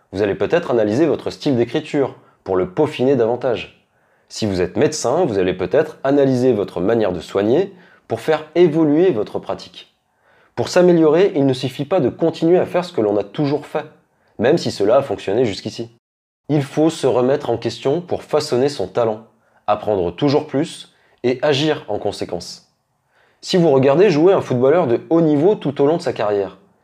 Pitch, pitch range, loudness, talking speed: 140 Hz, 115-155 Hz, -18 LUFS, 185 wpm